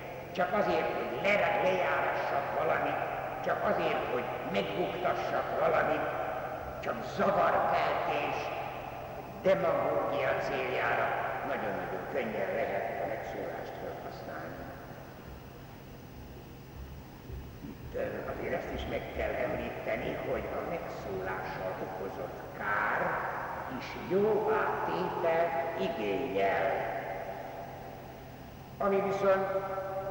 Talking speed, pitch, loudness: 75 wpm, 105 Hz, -32 LUFS